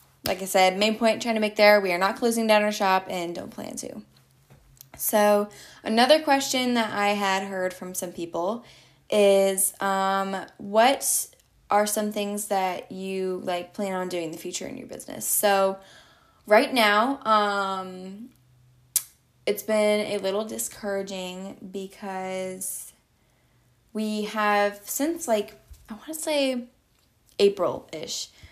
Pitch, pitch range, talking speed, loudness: 200 Hz, 185-215 Hz, 140 wpm, -24 LUFS